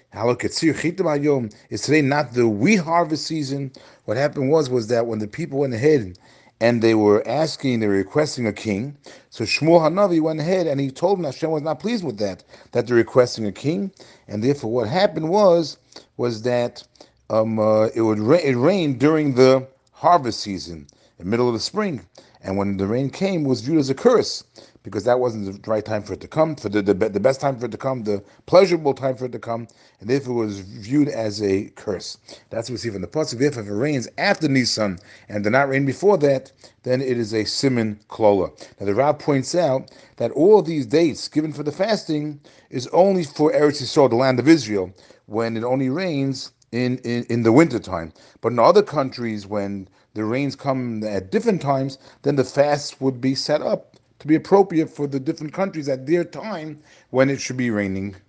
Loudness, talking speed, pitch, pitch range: -21 LUFS, 210 wpm, 130 Hz, 110-150 Hz